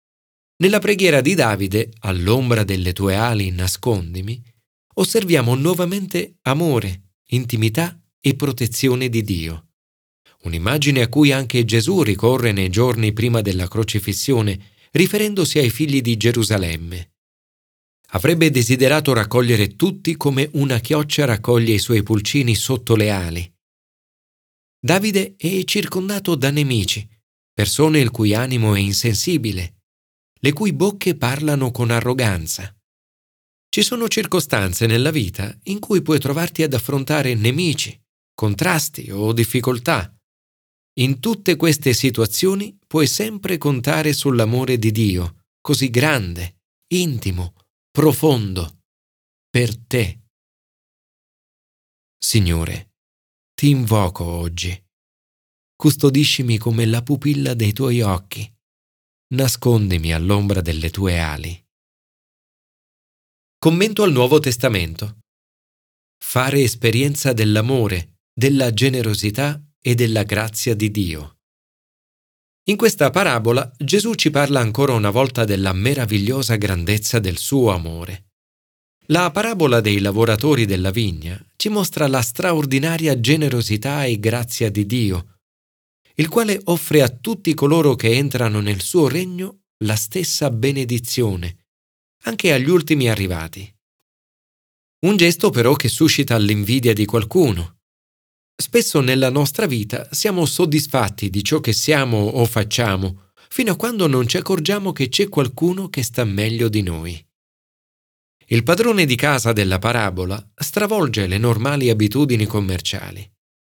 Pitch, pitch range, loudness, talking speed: 120 Hz, 100-150 Hz, -18 LUFS, 115 wpm